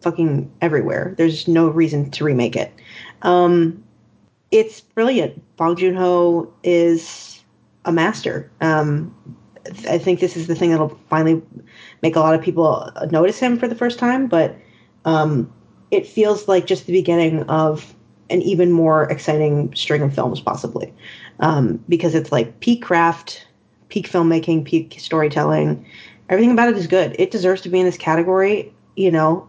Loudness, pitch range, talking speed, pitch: -18 LUFS, 155-180 Hz, 160 wpm, 165 Hz